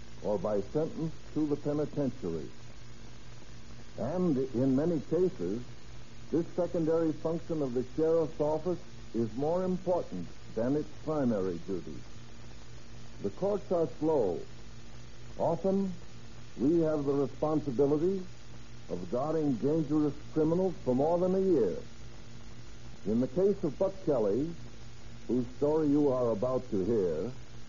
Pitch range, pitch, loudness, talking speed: 120-165 Hz, 145 Hz, -32 LUFS, 120 wpm